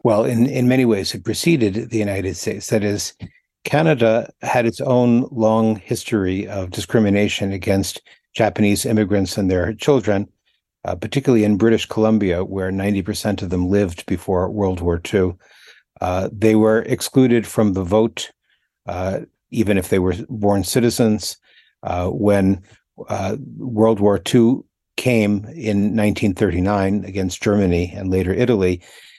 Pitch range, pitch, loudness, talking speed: 95-115 Hz, 105 Hz, -19 LUFS, 140 wpm